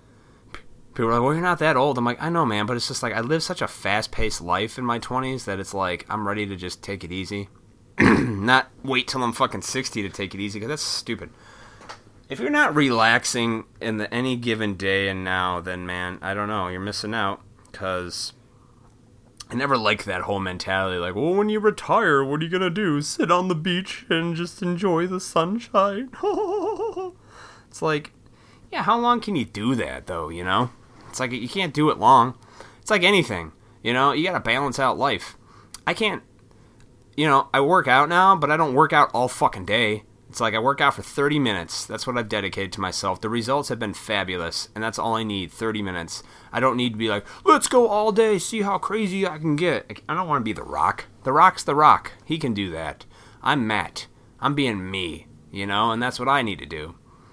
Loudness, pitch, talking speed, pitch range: -22 LUFS, 120 Hz, 220 wpm, 105-150 Hz